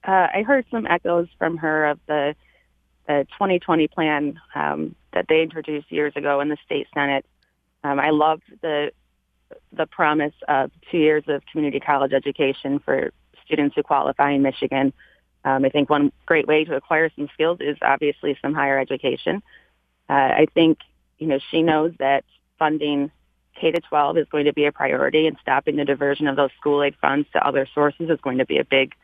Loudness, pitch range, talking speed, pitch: -21 LUFS, 140-155 Hz, 190 wpm, 145 Hz